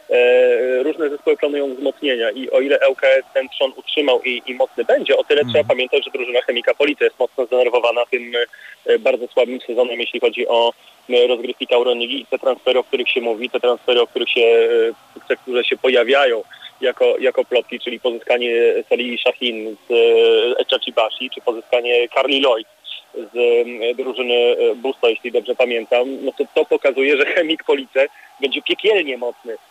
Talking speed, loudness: 160 wpm, -17 LUFS